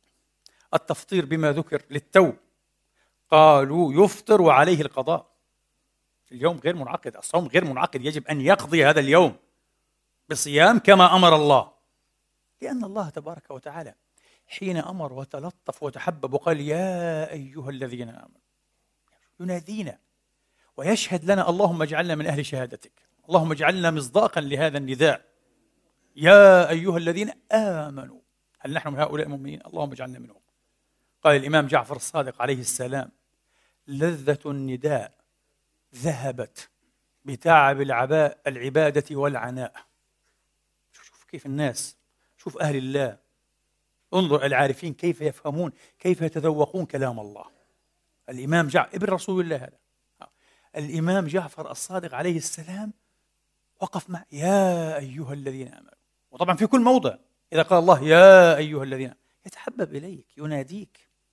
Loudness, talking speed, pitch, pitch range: -21 LUFS, 115 wpm, 155 Hz, 140-180 Hz